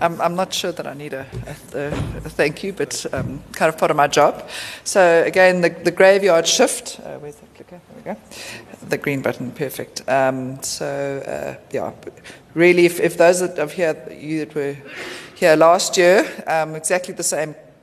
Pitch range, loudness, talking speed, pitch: 145-180 Hz, -18 LUFS, 185 wpm, 160 Hz